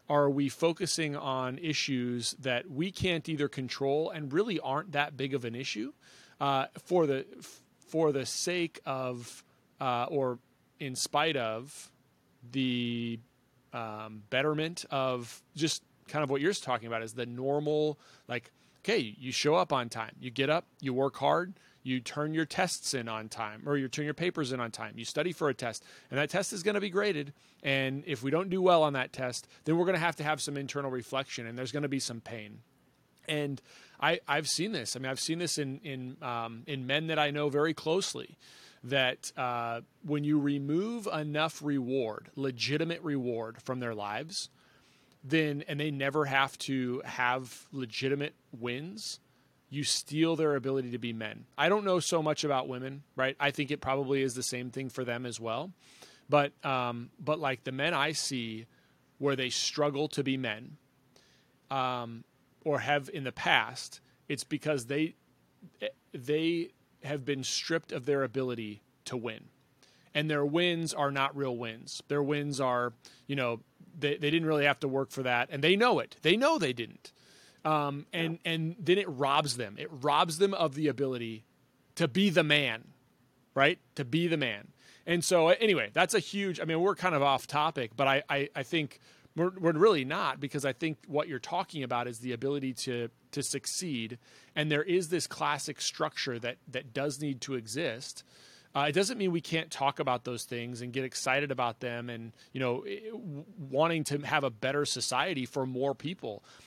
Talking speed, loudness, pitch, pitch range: 190 wpm, -32 LUFS, 140 Hz, 125-155 Hz